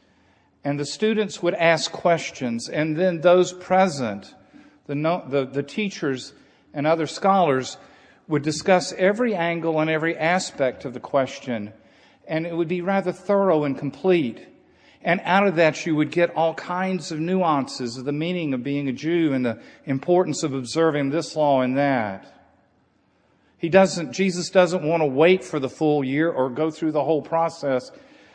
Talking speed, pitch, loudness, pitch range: 170 wpm, 160 Hz, -22 LUFS, 140-180 Hz